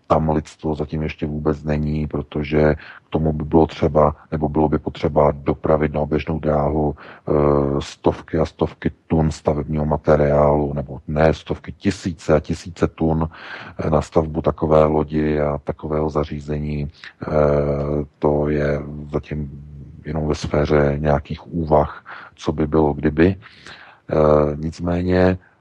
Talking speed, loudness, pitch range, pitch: 125 wpm, -20 LUFS, 75-80 Hz, 75 Hz